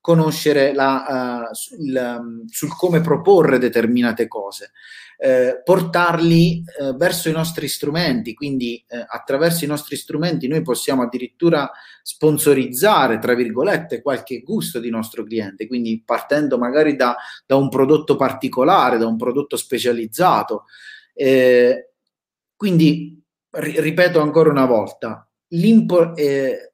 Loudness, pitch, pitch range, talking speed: -18 LUFS, 140 Hz, 120-160 Hz, 120 wpm